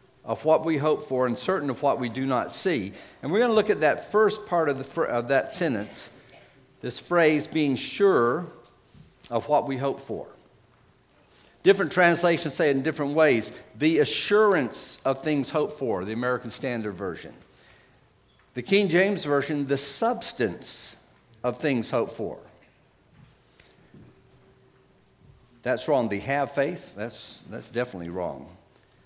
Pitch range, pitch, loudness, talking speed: 125-170 Hz, 140 Hz, -25 LUFS, 150 wpm